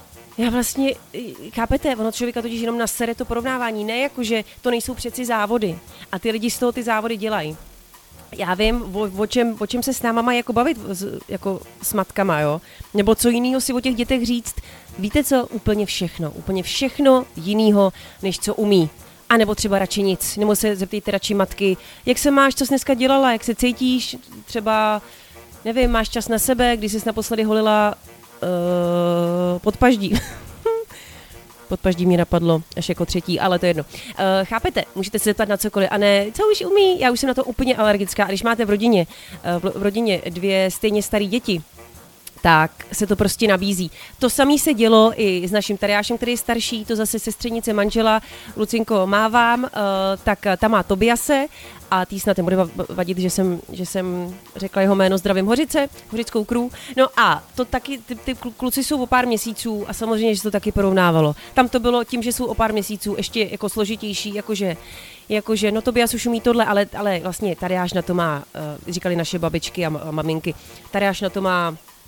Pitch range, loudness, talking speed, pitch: 190-235 Hz, -20 LUFS, 190 wpm, 215 Hz